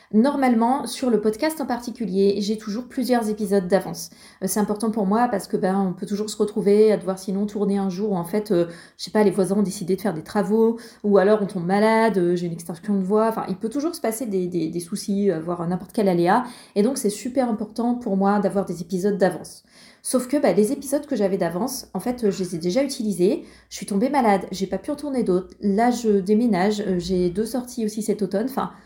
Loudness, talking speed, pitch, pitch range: -22 LUFS, 235 wpm, 205 Hz, 195-230 Hz